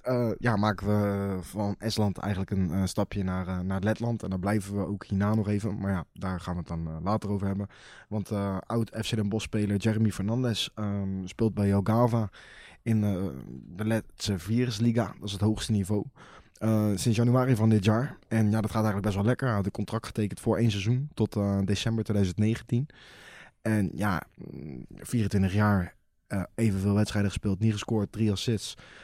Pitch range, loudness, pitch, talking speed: 100-110 Hz, -28 LUFS, 105 Hz, 190 wpm